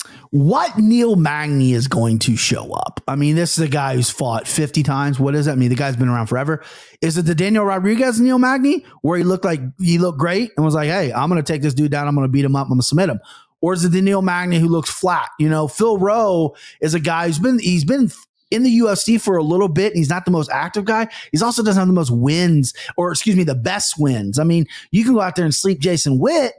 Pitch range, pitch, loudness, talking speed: 145-195 Hz, 165 Hz, -17 LUFS, 275 wpm